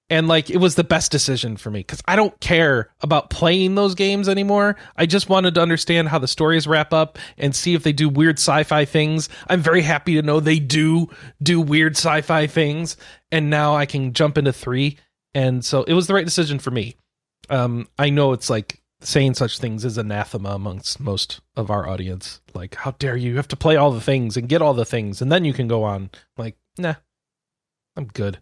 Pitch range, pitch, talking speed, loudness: 125-165 Hz, 150 Hz, 220 wpm, -19 LUFS